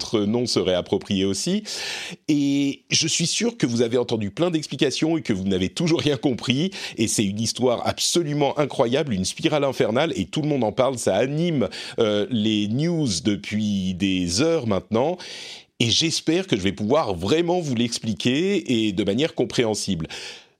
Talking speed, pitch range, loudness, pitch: 170 wpm, 105-160 Hz, -22 LUFS, 125 Hz